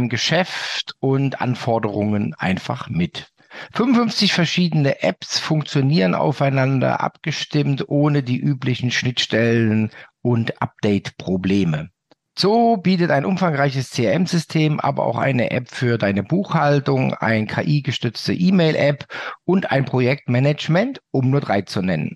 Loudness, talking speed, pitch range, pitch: -19 LUFS, 110 wpm, 120-160 Hz, 140 Hz